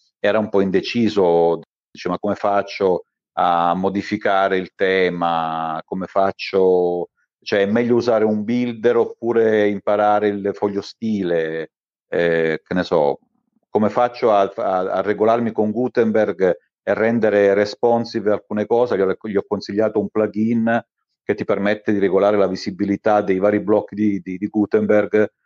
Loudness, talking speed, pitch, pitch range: -19 LUFS, 150 wpm, 105 Hz, 95-110 Hz